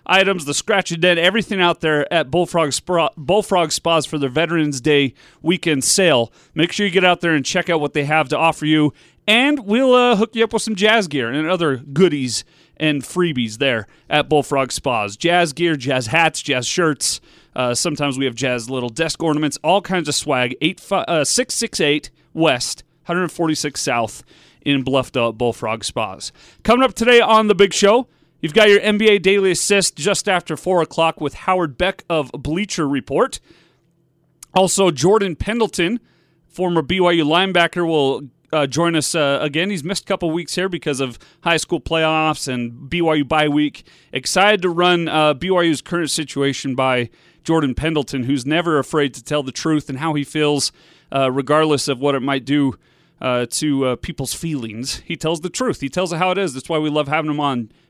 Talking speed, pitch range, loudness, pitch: 190 wpm, 145-180 Hz, -18 LUFS, 160 Hz